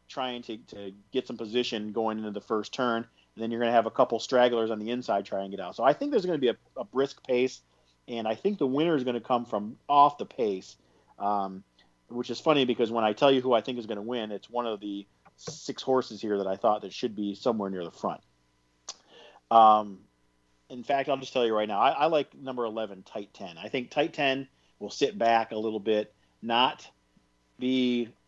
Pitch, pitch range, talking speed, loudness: 115 Hz, 100-125 Hz, 235 wpm, -28 LUFS